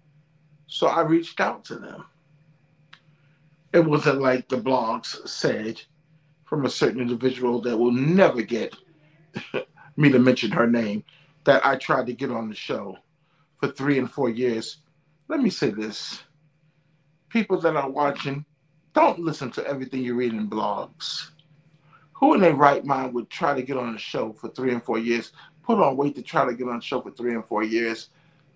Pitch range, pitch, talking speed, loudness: 125-155 Hz, 145 Hz, 180 wpm, -24 LUFS